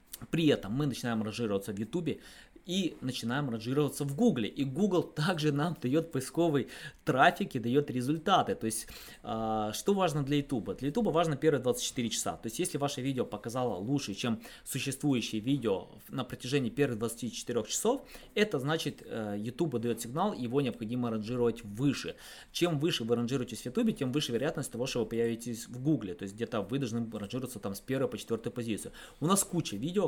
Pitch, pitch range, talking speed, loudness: 130 Hz, 115-150 Hz, 180 wpm, -32 LUFS